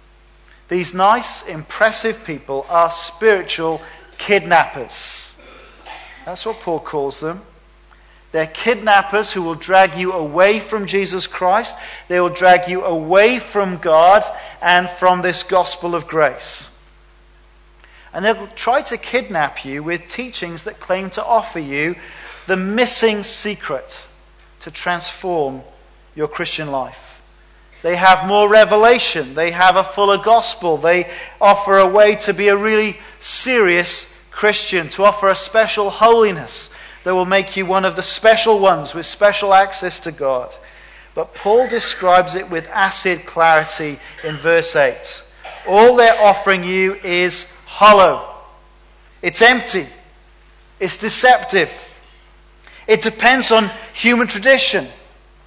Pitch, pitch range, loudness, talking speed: 190 Hz, 175-215 Hz, -15 LUFS, 130 wpm